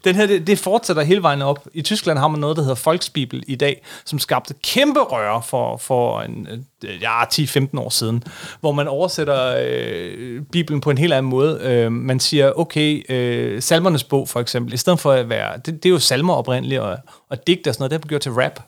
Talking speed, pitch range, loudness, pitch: 220 wpm, 125-165 Hz, -18 LUFS, 145 Hz